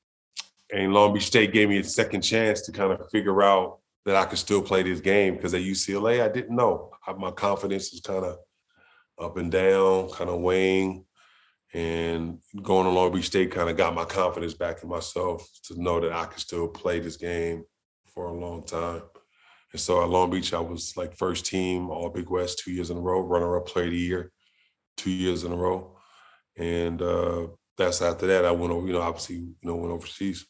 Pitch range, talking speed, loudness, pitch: 85-95 Hz, 215 wpm, -26 LUFS, 90 Hz